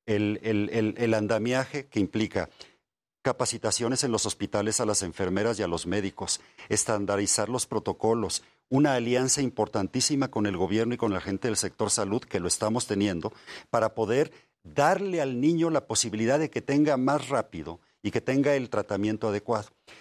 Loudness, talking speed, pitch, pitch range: -27 LUFS, 170 wpm, 110 Hz, 105-130 Hz